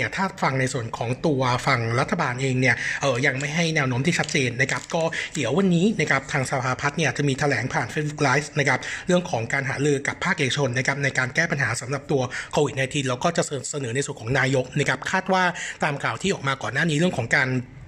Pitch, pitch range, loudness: 140 Hz, 130-160 Hz, -23 LUFS